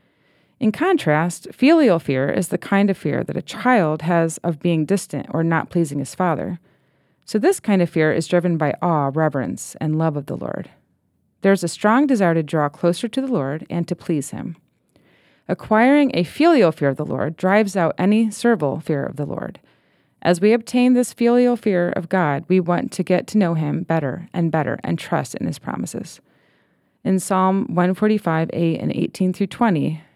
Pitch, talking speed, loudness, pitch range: 175 Hz, 195 wpm, -19 LUFS, 160-215 Hz